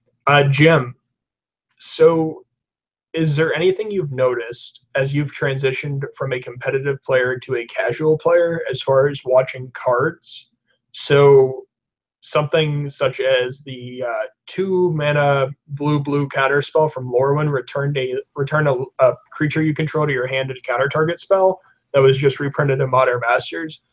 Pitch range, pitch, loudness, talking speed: 130-155 Hz, 140 Hz, -18 LUFS, 155 wpm